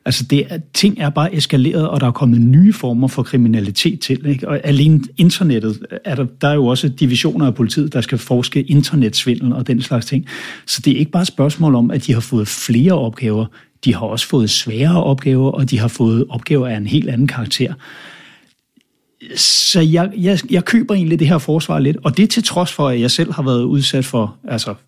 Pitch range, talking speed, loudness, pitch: 125-155 Hz, 215 wpm, -15 LUFS, 135 Hz